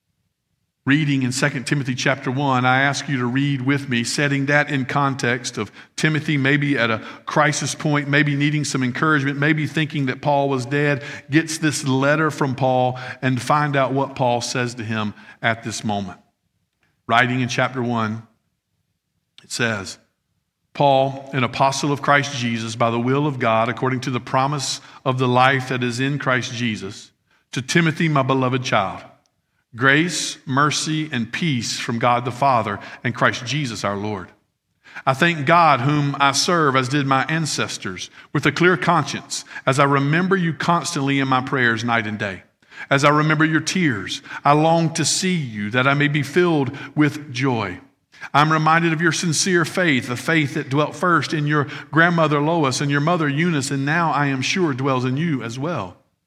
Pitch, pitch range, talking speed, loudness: 140 Hz, 125-150 Hz, 180 wpm, -19 LUFS